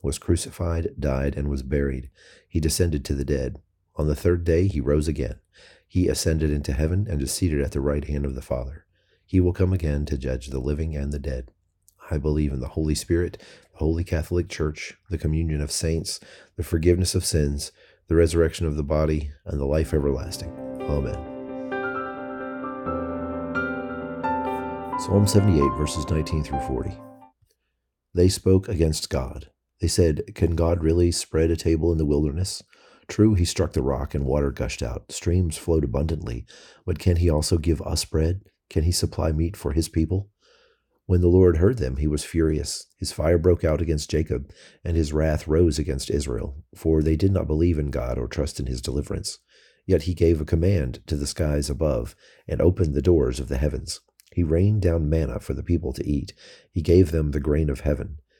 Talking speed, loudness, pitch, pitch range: 185 wpm, -24 LUFS, 80 Hz, 75-85 Hz